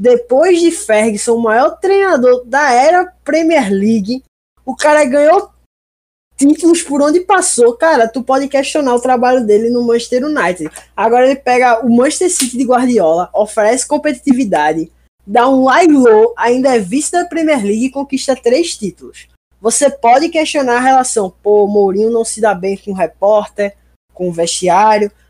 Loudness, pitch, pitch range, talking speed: -12 LUFS, 250 Hz, 215-290 Hz, 160 wpm